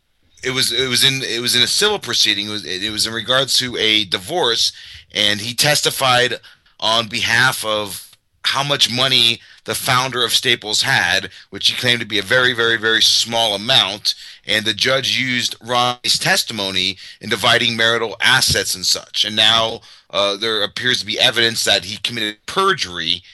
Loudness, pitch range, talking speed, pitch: -15 LUFS, 105-125 Hz, 175 wpm, 115 Hz